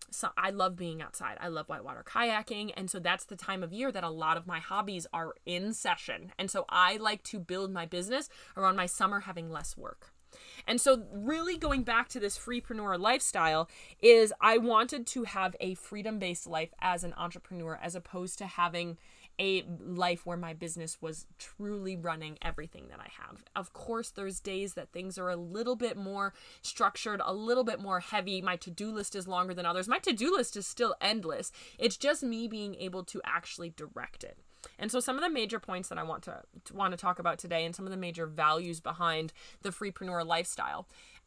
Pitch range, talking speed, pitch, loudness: 175-220 Hz, 205 wpm, 190 Hz, -33 LUFS